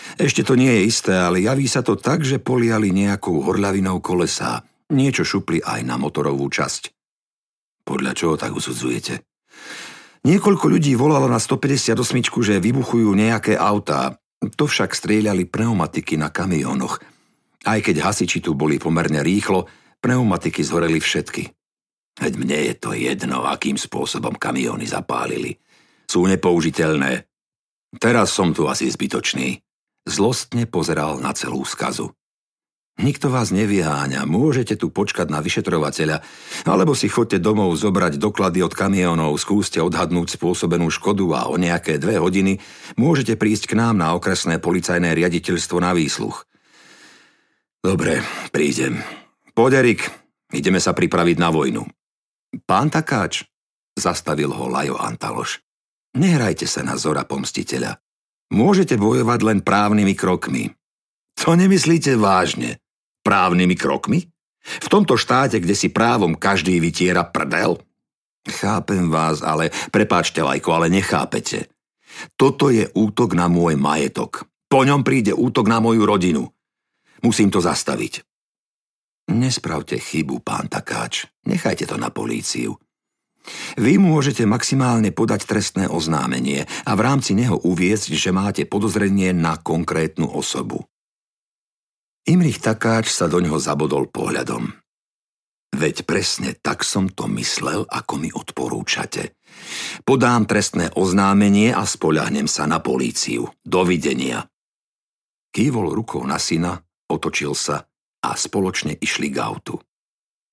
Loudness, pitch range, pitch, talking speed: -19 LUFS, 85-115 Hz, 100 Hz, 125 wpm